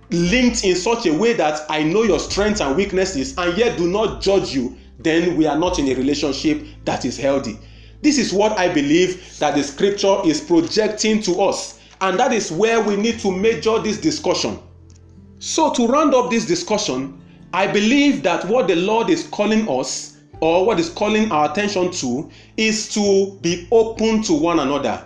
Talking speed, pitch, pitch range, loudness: 190 wpm, 195 Hz, 150-225 Hz, -18 LUFS